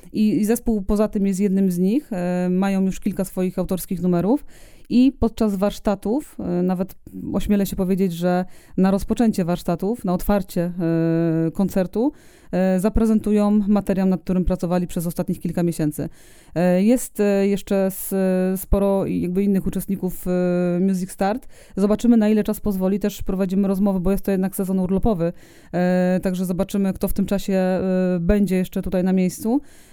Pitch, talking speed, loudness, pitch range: 195 Hz, 140 wpm, -21 LUFS, 180-205 Hz